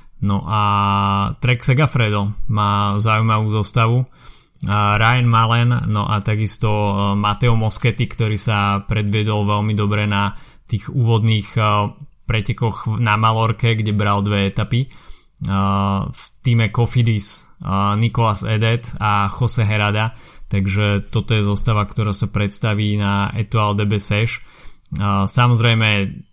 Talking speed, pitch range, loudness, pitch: 110 wpm, 100-115 Hz, -18 LUFS, 105 Hz